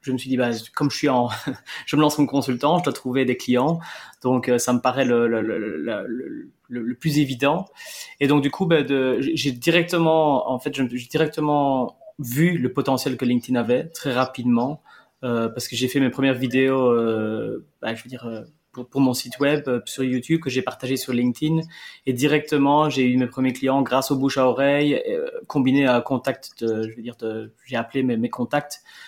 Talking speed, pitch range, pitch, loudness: 215 wpm, 125-145 Hz, 130 Hz, -22 LUFS